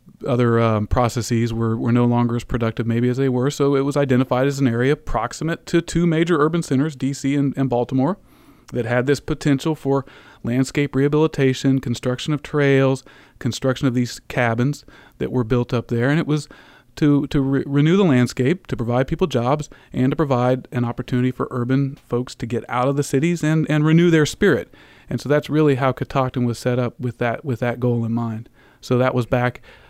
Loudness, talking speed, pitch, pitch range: -20 LUFS, 205 wpm, 130 Hz, 120-145 Hz